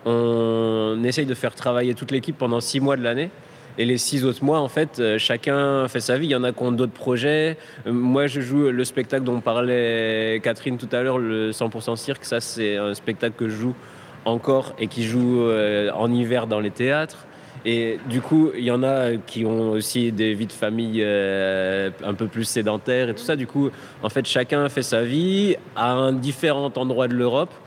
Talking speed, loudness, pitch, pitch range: 210 wpm, -22 LUFS, 125 Hz, 115-135 Hz